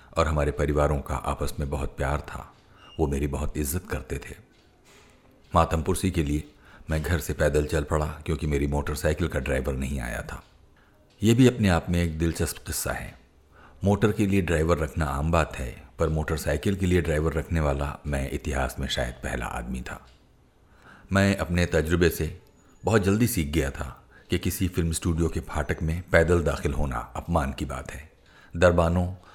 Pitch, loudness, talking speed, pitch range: 80 Hz, -26 LUFS, 180 wpm, 70-85 Hz